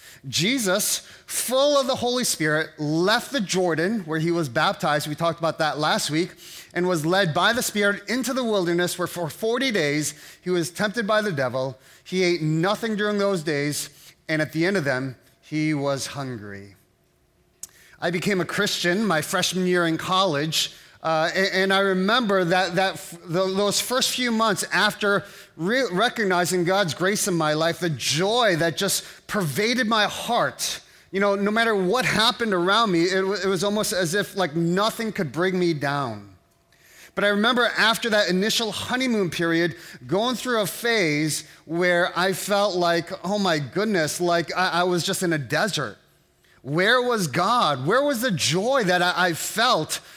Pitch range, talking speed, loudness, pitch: 160-205 Hz, 180 wpm, -22 LUFS, 185 Hz